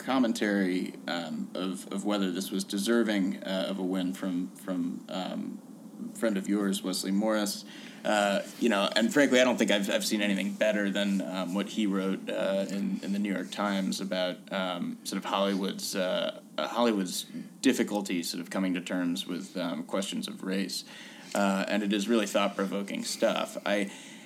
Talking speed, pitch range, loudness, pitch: 180 wpm, 95-110 Hz, -30 LUFS, 100 Hz